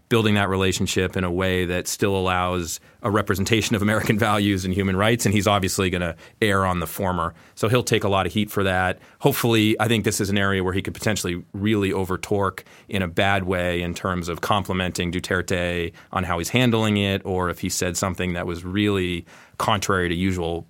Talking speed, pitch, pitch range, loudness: 210 wpm, 95 Hz, 90-105 Hz, -22 LUFS